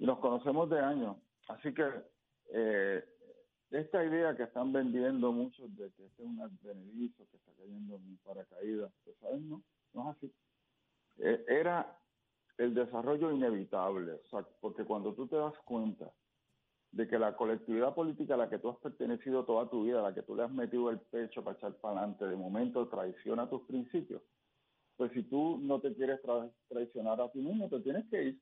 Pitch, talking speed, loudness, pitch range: 125 Hz, 195 wpm, -37 LUFS, 115-150 Hz